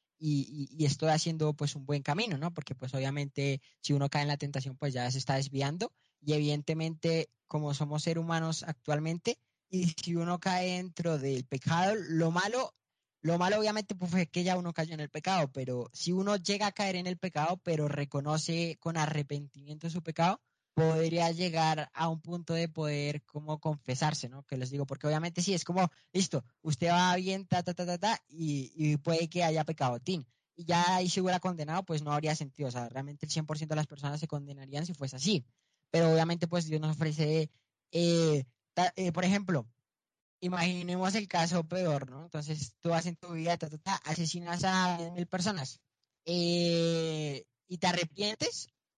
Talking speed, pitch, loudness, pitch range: 190 wpm, 160 Hz, -33 LUFS, 145-175 Hz